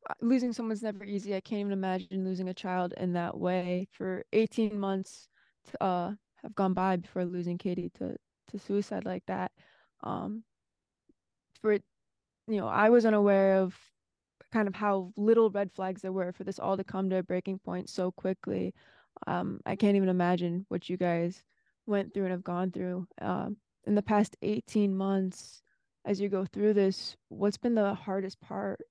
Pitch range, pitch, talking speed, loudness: 185-205 Hz, 195 Hz, 180 wpm, -31 LUFS